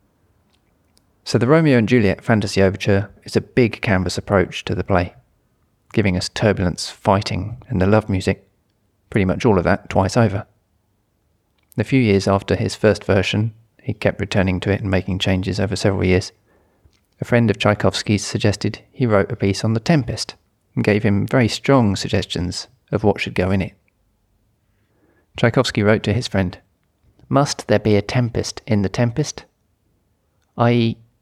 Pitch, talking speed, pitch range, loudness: 105 Hz, 165 wpm, 95-115 Hz, -19 LUFS